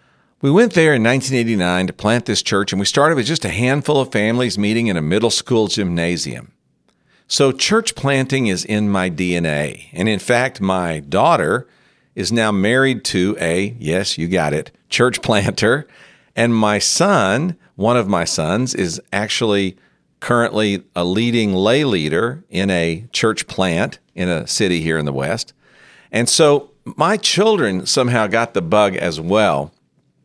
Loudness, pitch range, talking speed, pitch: -17 LUFS, 95-125 Hz, 165 wpm, 105 Hz